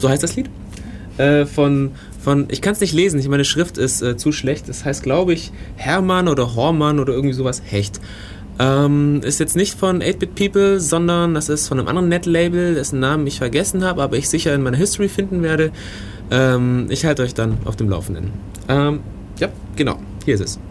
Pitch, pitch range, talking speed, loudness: 140 Hz, 120-165 Hz, 205 wpm, -18 LUFS